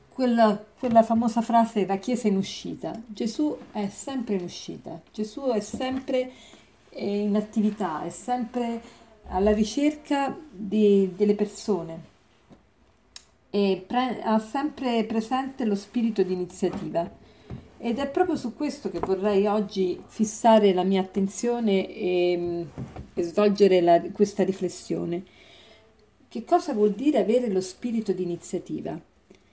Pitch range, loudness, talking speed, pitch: 190-240 Hz, -25 LUFS, 120 wpm, 210 Hz